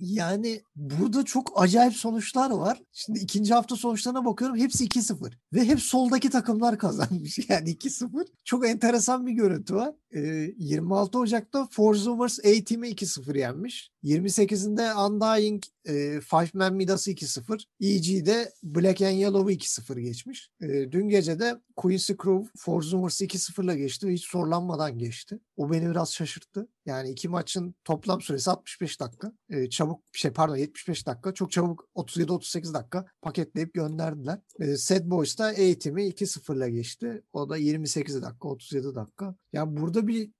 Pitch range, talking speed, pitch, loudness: 160-220 Hz, 145 wpm, 190 Hz, -27 LUFS